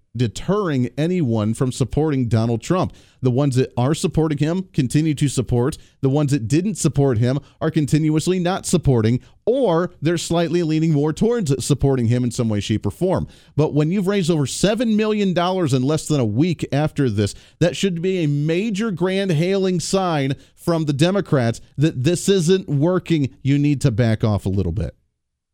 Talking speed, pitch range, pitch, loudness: 180 wpm, 130-175 Hz, 150 Hz, -20 LUFS